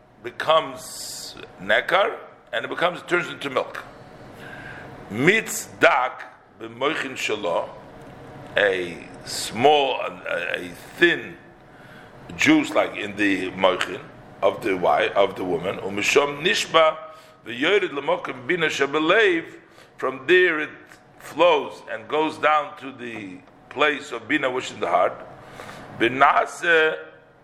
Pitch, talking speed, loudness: 160 Hz, 110 wpm, -21 LUFS